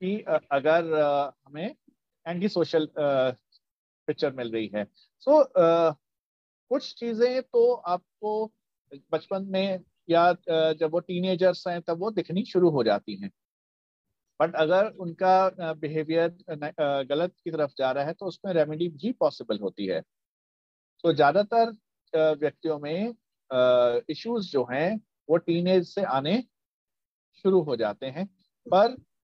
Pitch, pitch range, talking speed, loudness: 165 Hz, 145-190 Hz, 135 wpm, -26 LUFS